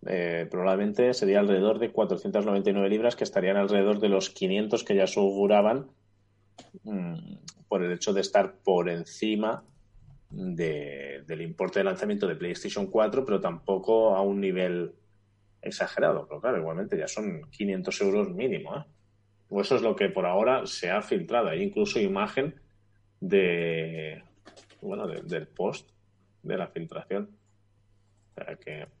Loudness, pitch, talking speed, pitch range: -28 LUFS, 100 Hz, 150 wpm, 100-140 Hz